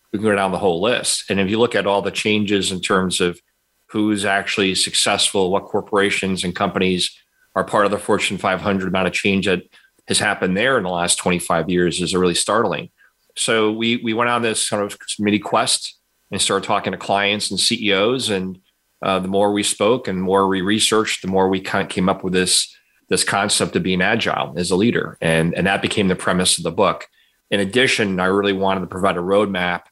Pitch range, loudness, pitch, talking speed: 95-105 Hz, -18 LUFS, 95 Hz, 220 wpm